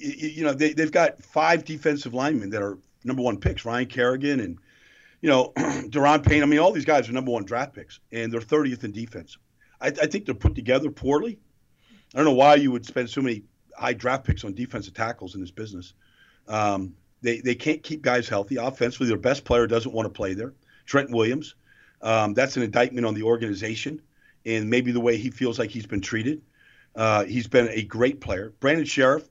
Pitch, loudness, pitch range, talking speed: 120 Hz, -24 LUFS, 110-140 Hz, 210 wpm